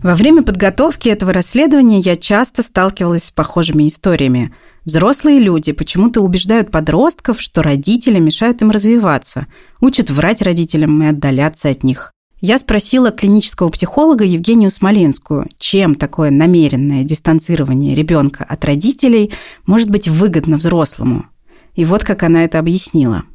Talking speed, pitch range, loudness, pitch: 130 wpm, 155-215 Hz, -12 LUFS, 175 Hz